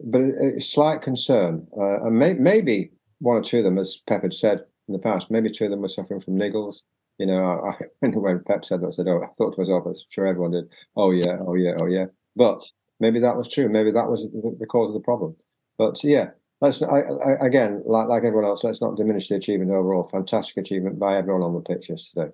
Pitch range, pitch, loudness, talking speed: 95-120 Hz, 105 Hz, -22 LUFS, 245 wpm